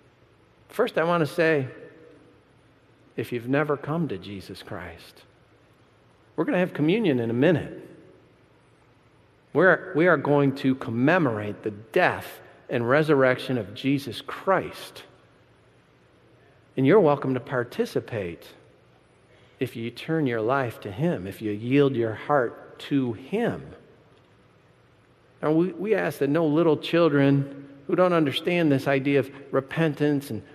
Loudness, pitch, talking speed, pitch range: -24 LUFS, 140 Hz, 135 wpm, 120-160 Hz